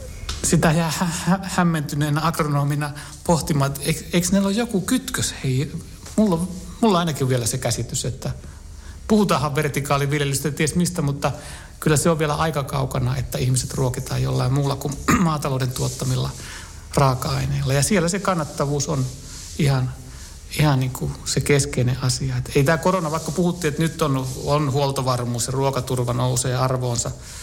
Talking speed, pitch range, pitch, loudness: 155 wpm, 130-160 Hz, 140 Hz, -22 LUFS